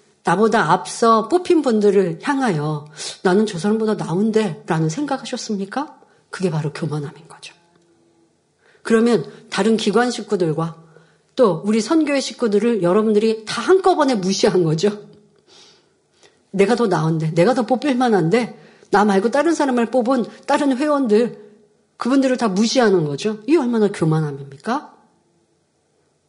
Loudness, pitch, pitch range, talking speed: -18 LUFS, 215 Hz, 180-245 Hz, 295 characters per minute